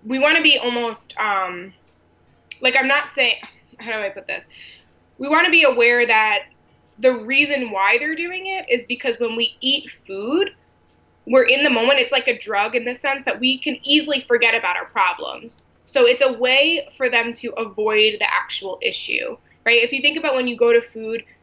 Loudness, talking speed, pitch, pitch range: -18 LUFS, 205 wpm, 255 Hz, 230-285 Hz